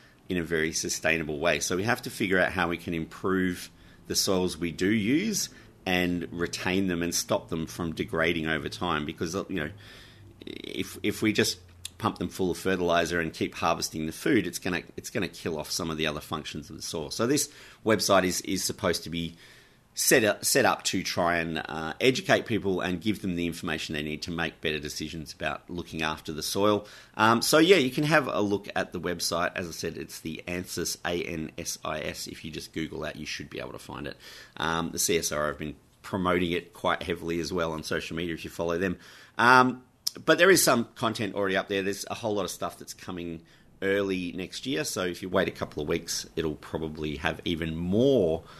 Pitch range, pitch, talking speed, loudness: 80-100 Hz, 90 Hz, 220 wpm, -28 LUFS